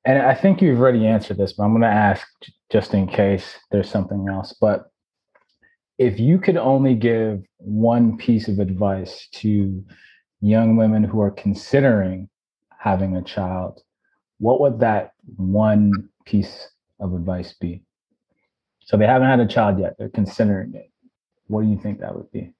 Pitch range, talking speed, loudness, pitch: 100-120 Hz, 165 wpm, -19 LUFS, 105 Hz